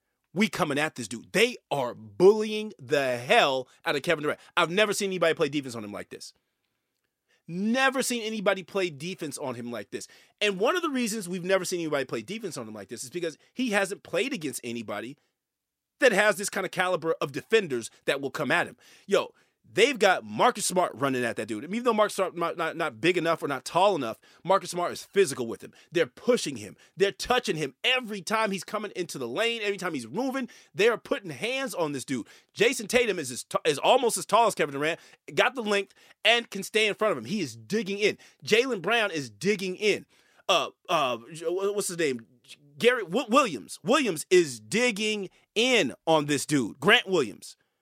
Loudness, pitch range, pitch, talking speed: -27 LUFS, 160-220 Hz, 195 Hz, 210 wpm